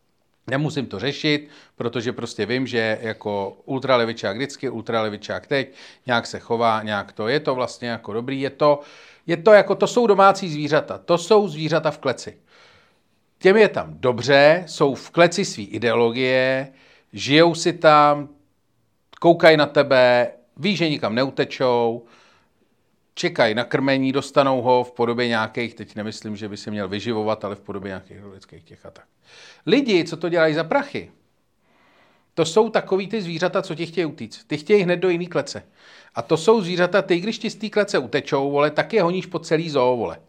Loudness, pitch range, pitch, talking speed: -20 LUFS, 115-170 Hz, 140 Hz, 175 wpm